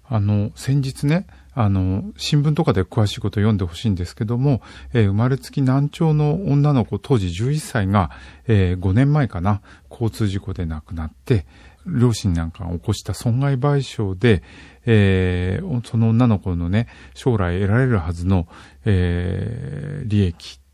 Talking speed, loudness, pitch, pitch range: 285 characters per minute, -20 LUFS, 105 Hz, 95-125 Hz